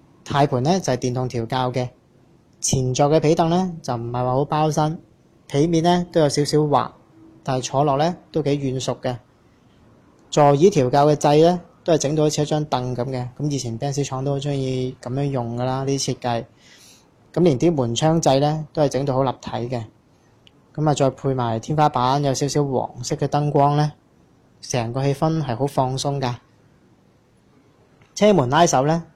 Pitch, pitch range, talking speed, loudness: 140 Hz, 125-150 Hz, 255 characters per minute, -20 LUFS